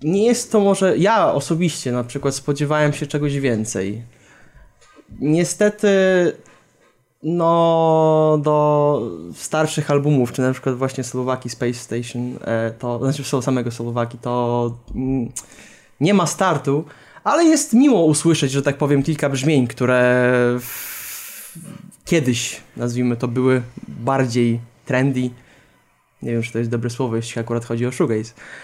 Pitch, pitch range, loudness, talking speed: 135 Hz, 120-155 Hz, -19 LUFS, 135 wpm